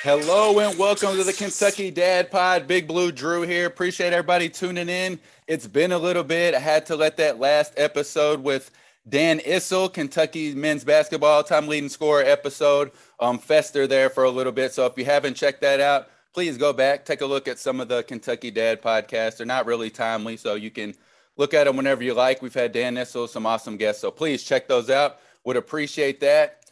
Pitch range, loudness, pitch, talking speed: 130-180 Hz, -22 LUFS, 150 Hz, 210 wpm